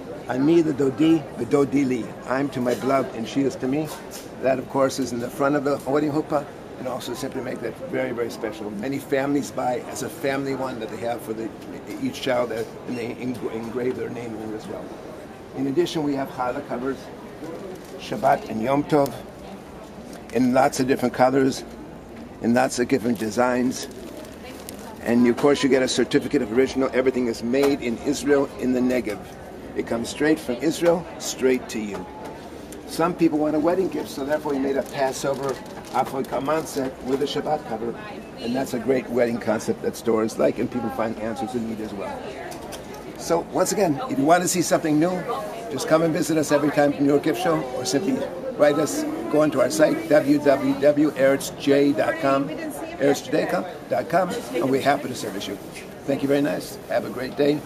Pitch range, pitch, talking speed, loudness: 125-145 Hz, 135 Hz, 190 wpm, -23 LUFS